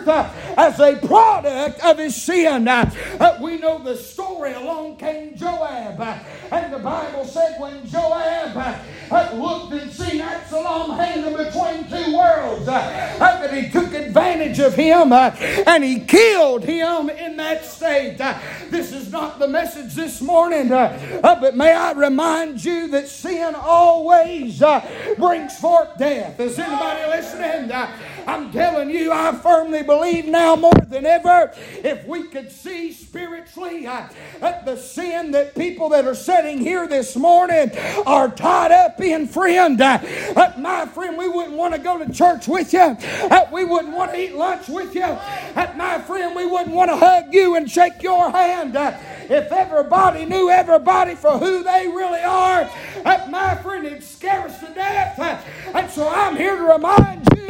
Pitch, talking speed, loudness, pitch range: 330 Hz, 170 wpm, -17 LUFS, 300-355 Hz